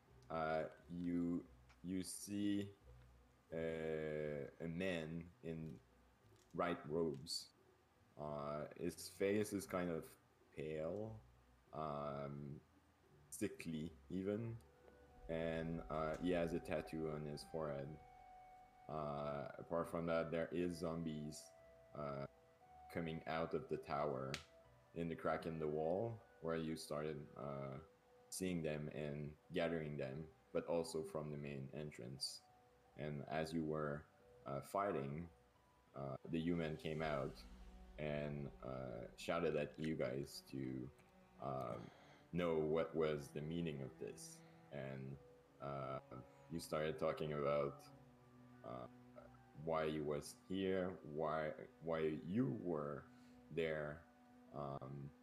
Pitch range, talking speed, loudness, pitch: 70-85 Hz, 115 wpm, -46 LUFS, 80 Hz